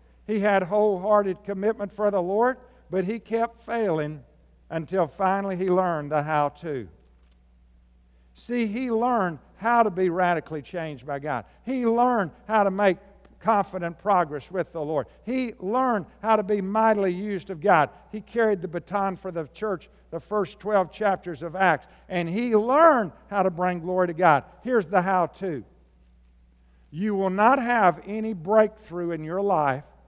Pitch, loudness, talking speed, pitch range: 190 Hz, -25 LUFS, 165 wpm, 165-215 Hz